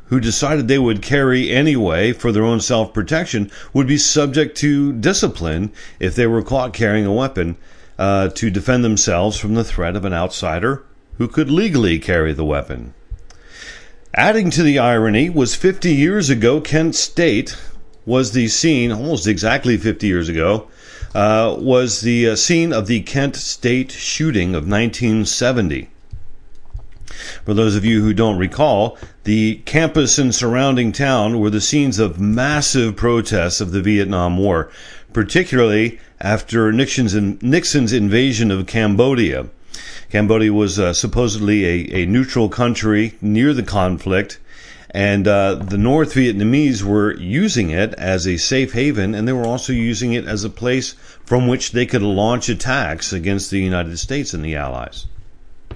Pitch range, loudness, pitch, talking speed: 100-130 Hz, -16 LUFS, 110 Hz, 155 wpm